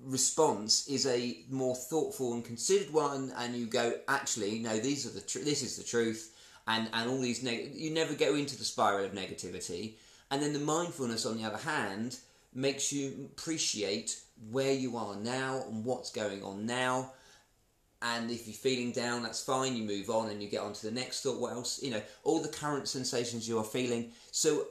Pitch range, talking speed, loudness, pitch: 115-135 Hz, 200 wpm, -34 LUFS, 120 Hz